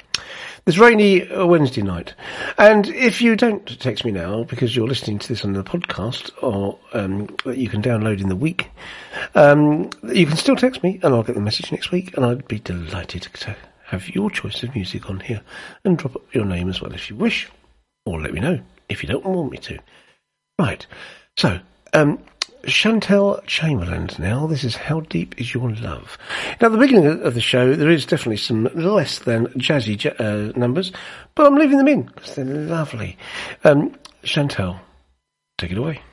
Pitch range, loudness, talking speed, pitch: 105-175 Hz, -19 LUFS, 190 wpm, 130 Hz